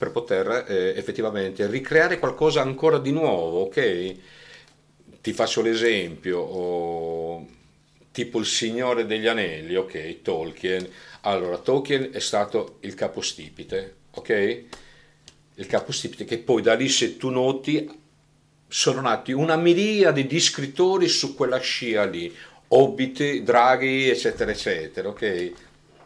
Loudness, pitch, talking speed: -23 LUFS, 140 Hz, 120 wpm